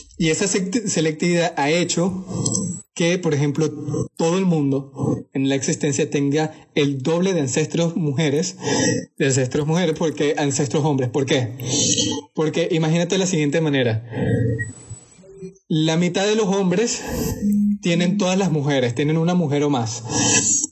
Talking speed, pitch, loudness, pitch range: 140 wpm, 160 Hz, -20 LUFS, 145-180 Hz